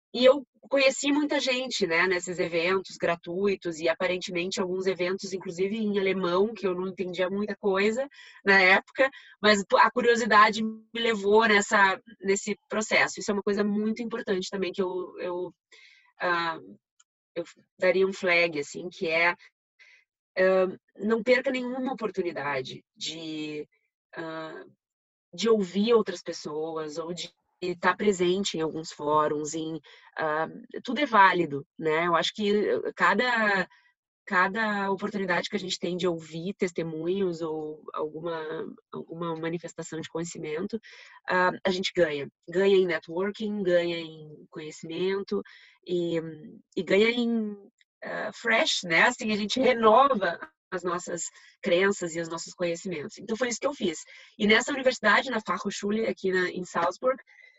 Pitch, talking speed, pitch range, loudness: 190 Hz, 145 wpm, 170-215 Hz, -26 LUFS